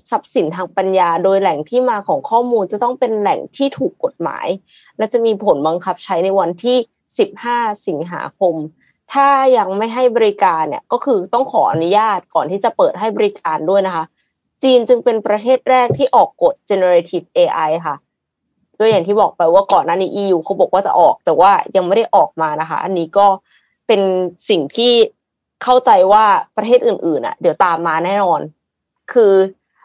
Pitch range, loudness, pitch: 190-250 Hz, -15 LUFS, 210 Hz